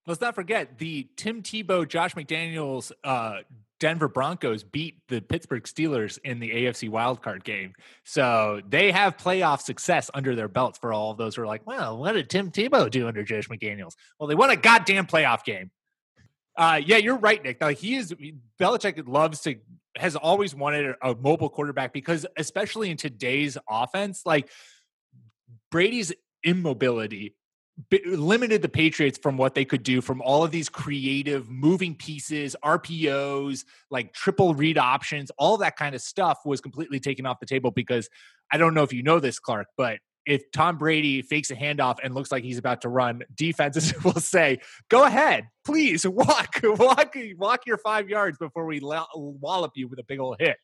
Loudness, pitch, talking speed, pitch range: -24 LUFS, 150 Hz, 180 wpm, 130-175 Hz